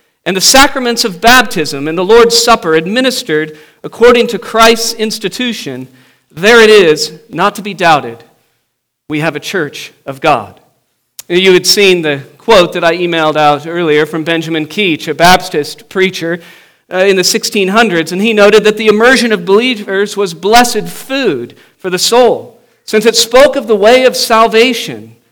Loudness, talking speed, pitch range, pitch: -9 LUFS, 165 wpm, 165-230 Hz, 200 Hz